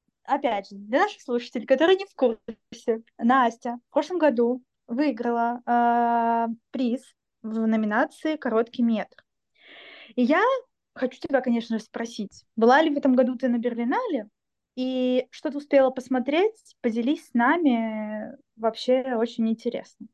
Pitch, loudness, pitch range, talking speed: 245 Hz, -25 LUFS, 230-275 Hz, 135 wpm